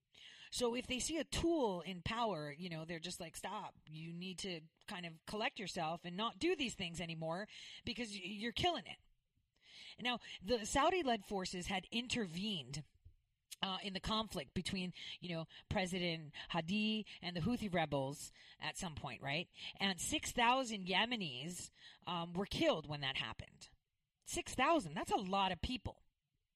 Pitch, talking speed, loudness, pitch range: 190 Hz, 160 wpm, -40 LUFS, 170-230 Hz